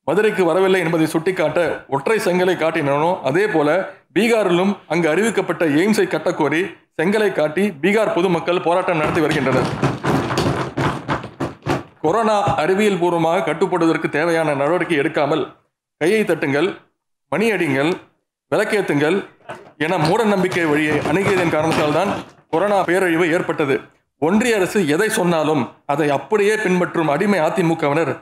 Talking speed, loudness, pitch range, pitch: 110 wpm, -18 LUFS, 160-195 Hz, 175 Hz